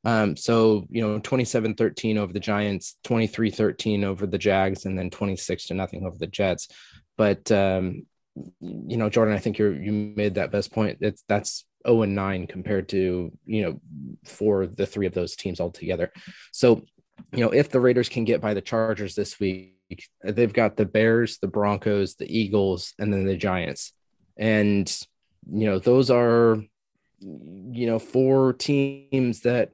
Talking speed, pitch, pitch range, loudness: 175 wpm, 105 Hz, 95-115 Hz, -24 LUFS